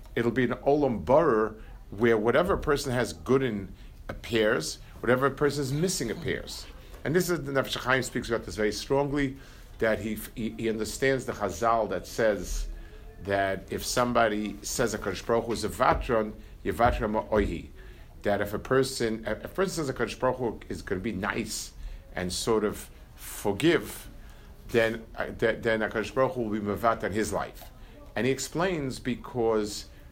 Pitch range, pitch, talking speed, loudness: 105-130 Hz, 115 Hz, 160 wpm, -28 LUFS